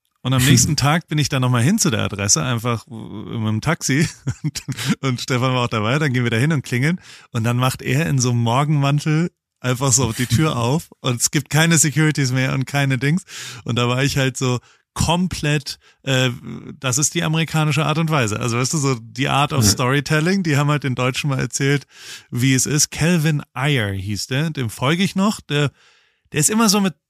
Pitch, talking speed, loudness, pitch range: 135 Hz, 215 wpm, -19 LUFS, 125-155 Hz